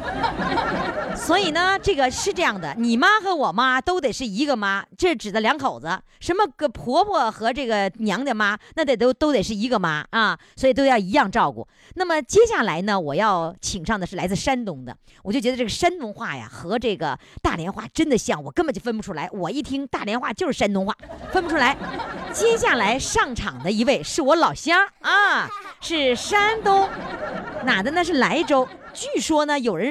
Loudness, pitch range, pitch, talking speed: -21 LUFS, 220-350 Hz, 265 Hz, 285 characters per minute